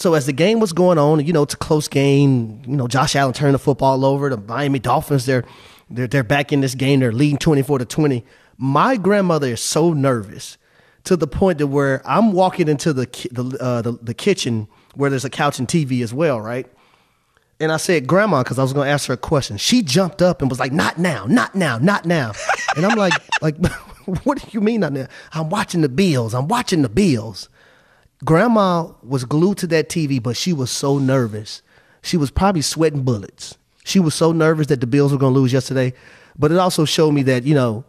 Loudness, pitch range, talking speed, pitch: -18 LUFS, 130-165 Hz, 225 wpm, 145 Hz